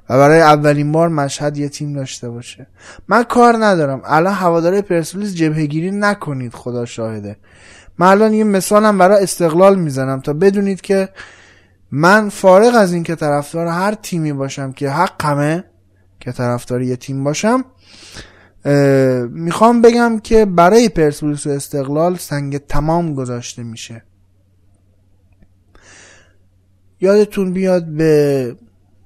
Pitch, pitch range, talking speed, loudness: 145 Hz, 120-180 Hz, 125 wpm, -14 LUFS